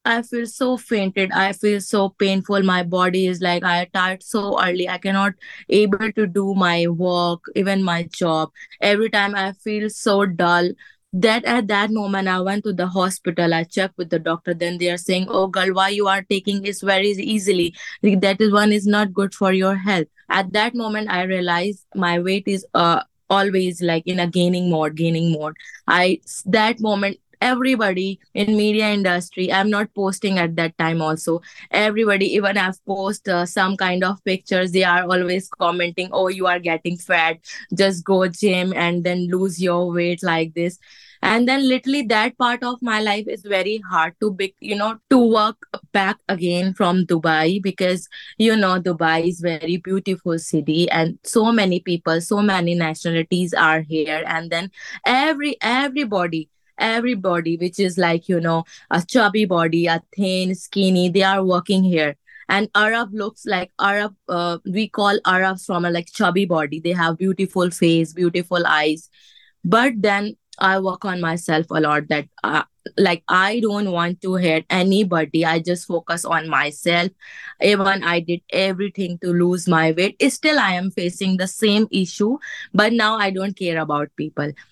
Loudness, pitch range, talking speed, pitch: -19 LUFS, 175-205 Hz, 175 wpm, 185 Hz